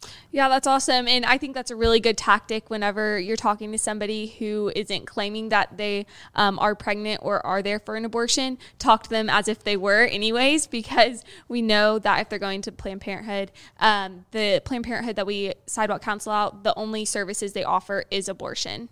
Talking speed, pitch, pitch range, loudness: 205 wpm, 215 Hz, 205-230 Hz, -23 LUFS